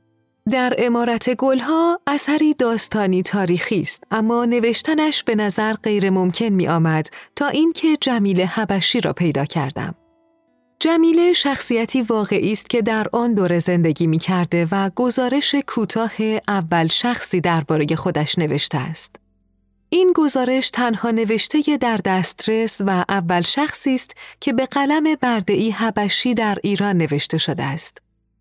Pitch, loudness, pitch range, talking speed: 220 Hz, -18 LUFS, 180-255 Hz, 130 wpm